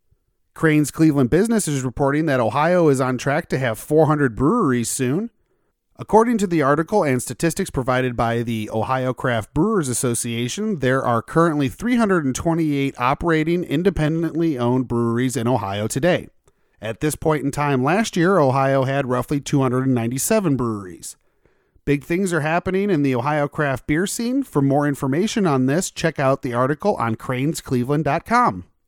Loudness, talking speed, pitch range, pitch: -20 LUFS, 150 wpm, 130-165 Hz, 145 Hz